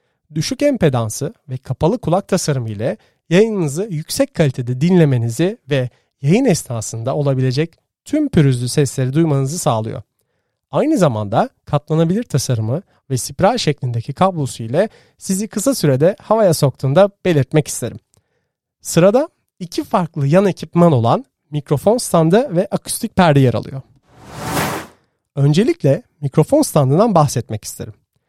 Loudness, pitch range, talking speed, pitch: -17 LUFS, 130-185 Hz, 115 wpm, 150 Hz